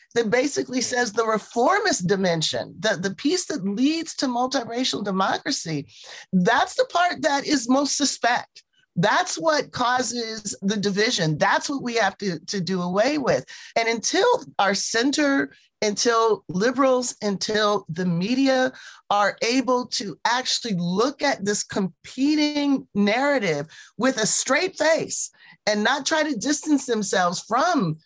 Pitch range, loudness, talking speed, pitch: 205-285 Hz, -22 LUFS, 135 wpm, 245 Hz